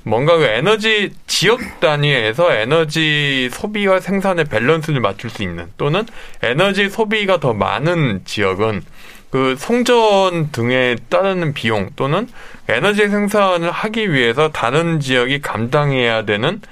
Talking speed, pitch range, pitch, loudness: 280 characters per minute, 125-195 Hz, 160 Hz, -16 LUFS